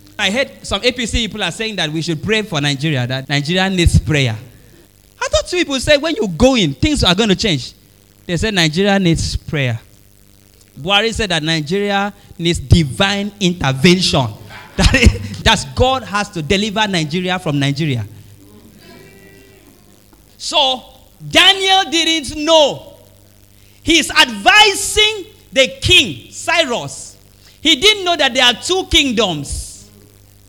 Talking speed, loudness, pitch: 135 wpm, -14 LUFS, 175 Hz